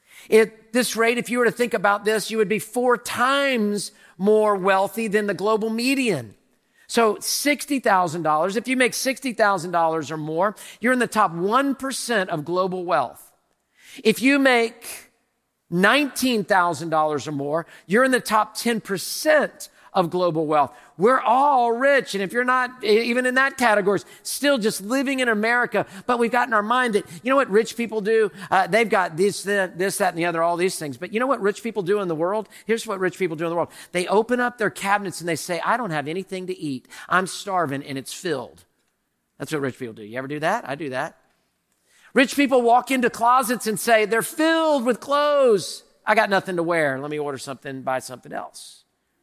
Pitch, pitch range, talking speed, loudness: 215 Hz, 180-245 Hz, 200 wpm, -21 LUFS